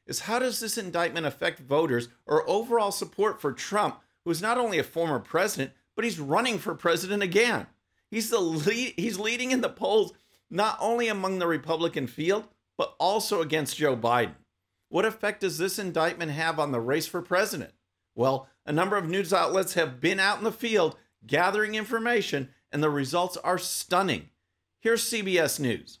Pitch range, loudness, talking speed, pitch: 155-215 Hz, -27 LUFS, 180 wpm, 180 Hz